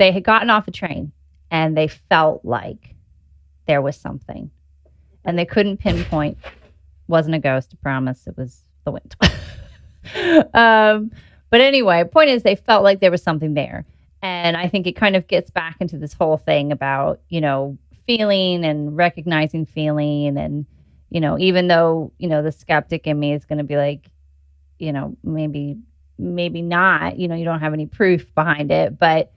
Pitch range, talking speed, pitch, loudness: 135-180 Hz, 180 wpm, 155 Hz, -18 LUFS